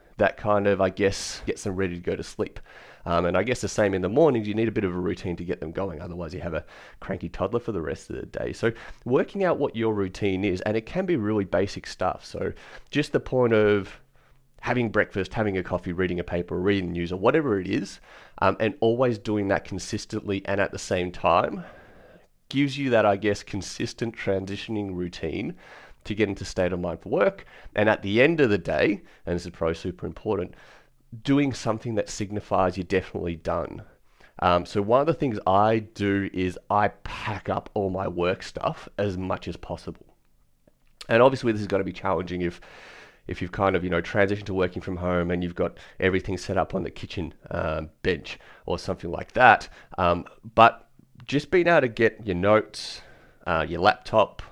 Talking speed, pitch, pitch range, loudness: 210 wpm, 100 Hz, 90-110 Hz, -25 LUFS